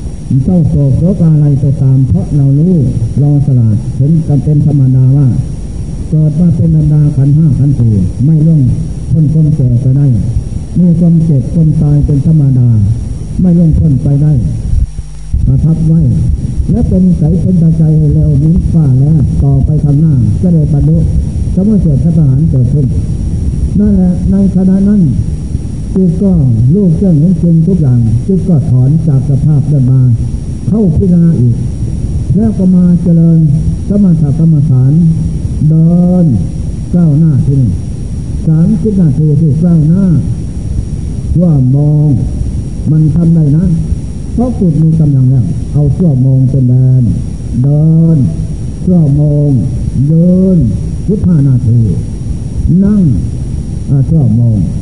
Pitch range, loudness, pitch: 130-165 Hz, -9 LUFS, 145 Hz